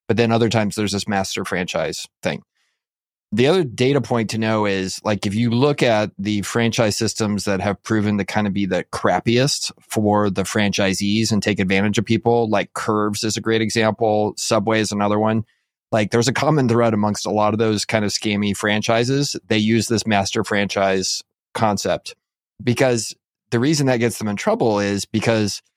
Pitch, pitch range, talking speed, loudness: 110 Hz, 100-115 Hz, 190 wpm, -19 LUFS